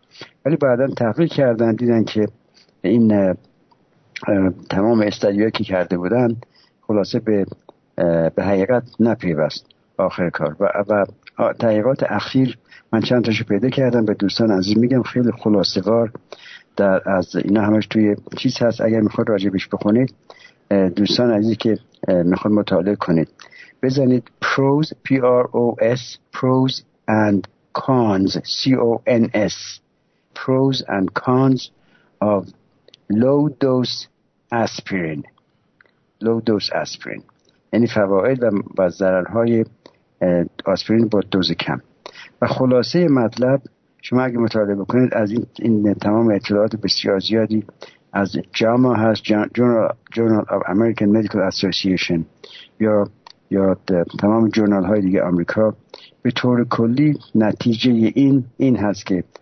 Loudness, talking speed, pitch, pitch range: -18 LUFS, 115 wpm, 110 Hz, 100-125 Hz